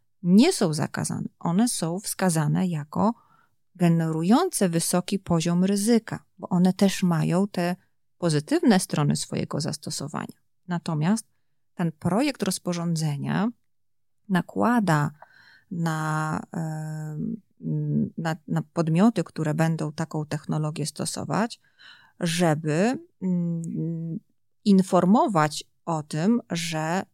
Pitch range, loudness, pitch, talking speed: 160-200 Hz, -25 LUFS, 175 Hz, 85 wpm